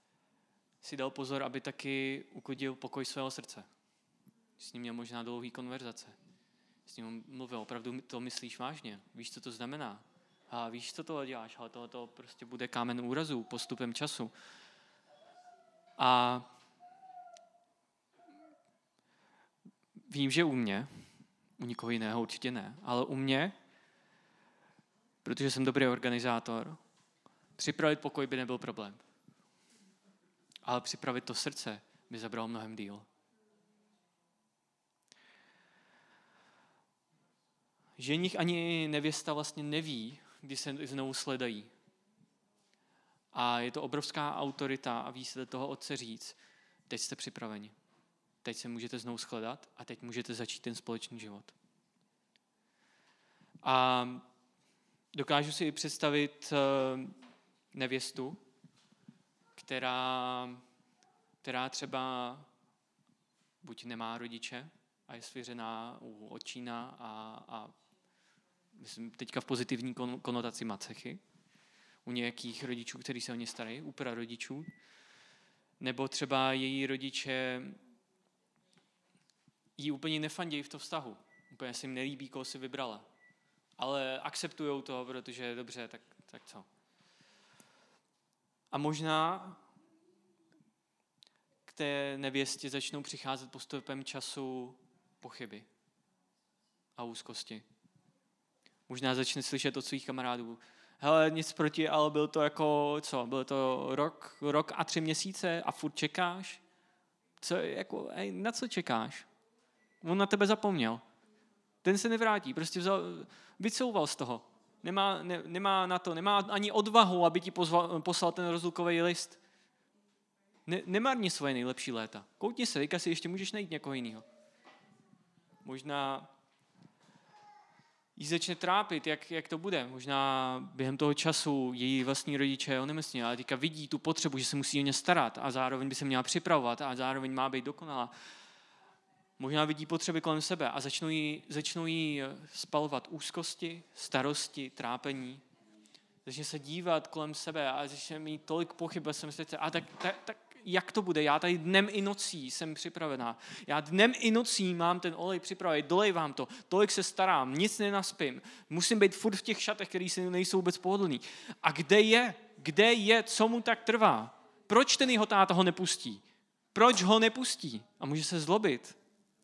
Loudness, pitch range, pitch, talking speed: -34 LUFS, 130-185 Hz, 150 Hz, 130 wpm